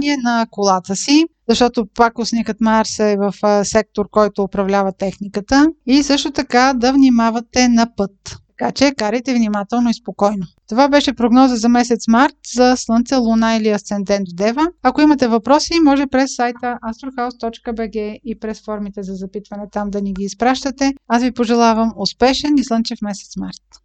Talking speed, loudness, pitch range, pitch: 160 wpm, -16 LUFS, 205-255 Hz, 230 Hz